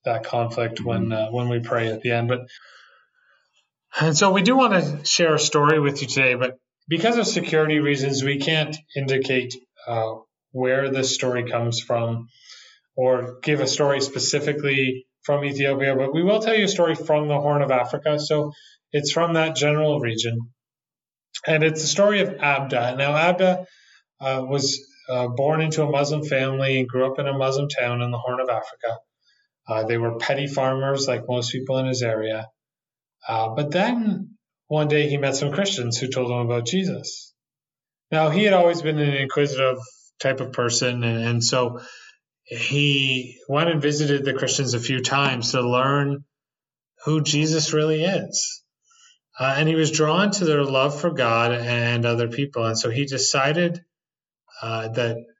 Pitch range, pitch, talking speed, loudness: 125-155 Hz, 140 Hz, 175 wpm, -22 LUFS